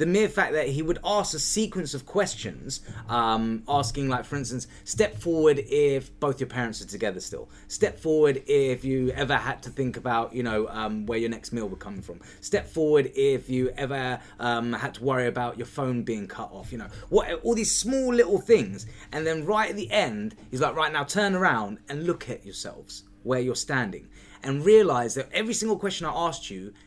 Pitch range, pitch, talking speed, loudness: 115-160 Hz, 135 Hz, 210 wpm, -26 LUFS